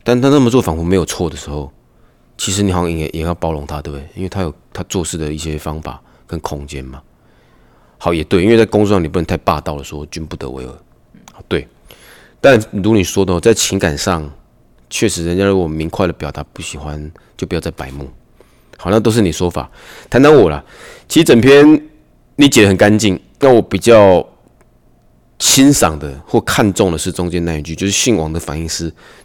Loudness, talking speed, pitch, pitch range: -13 LUFS, 290 characters per minute, 85 Hz, 75-100 Hz